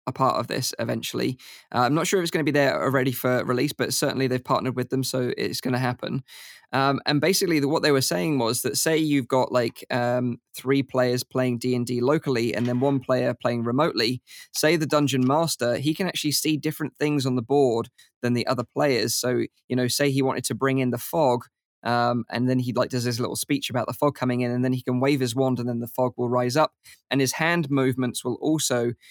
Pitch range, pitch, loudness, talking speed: 125-145 Hz, 130 Hz, -24 LUFS, 240 wpm